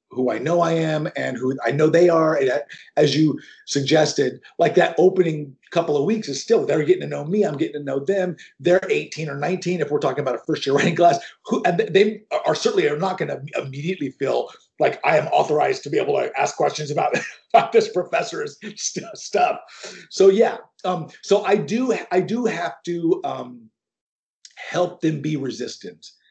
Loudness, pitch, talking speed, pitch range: -21 LUFS, 170 Hz, 200 wpm, 150-205 Hz